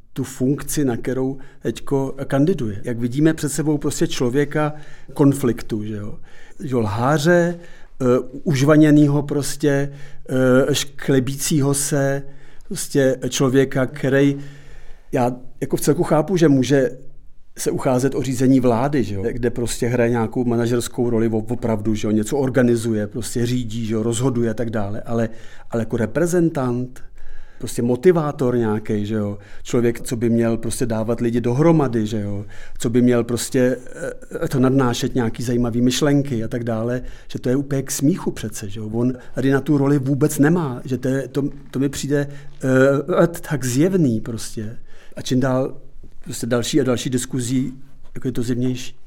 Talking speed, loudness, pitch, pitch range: 155 wpm, -20 LUFS, 130 Hz, 120-140 Hz